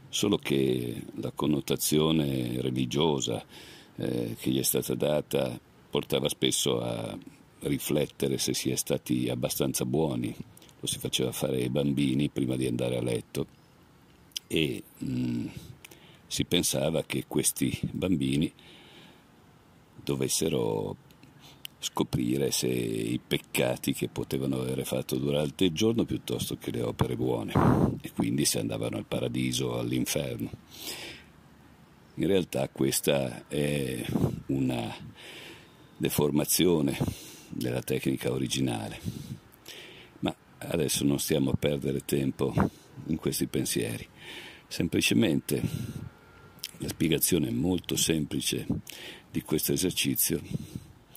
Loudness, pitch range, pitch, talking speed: -29 LUFS, 65-70 Hz, 65 Hz, 105 wpm